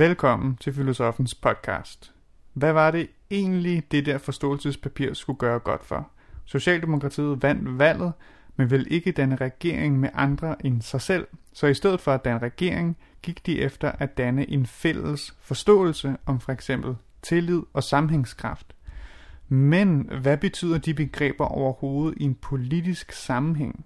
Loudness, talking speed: -25 LUFS, 145 wpm